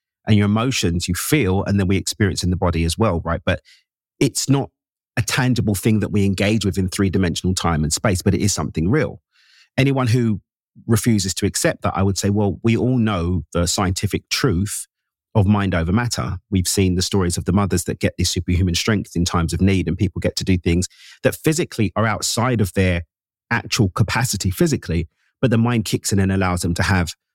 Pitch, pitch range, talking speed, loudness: 100 Hz, 90-110 Hz, 215 wpm, -19 LUFS